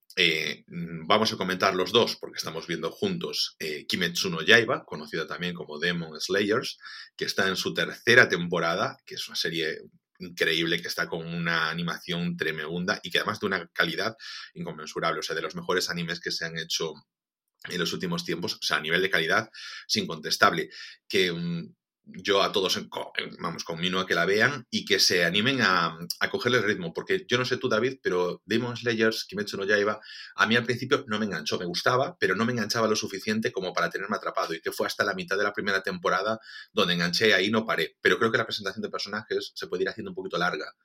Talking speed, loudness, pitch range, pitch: 215 wpm, -26 LUFS, 85-120 Hz, 100 Hz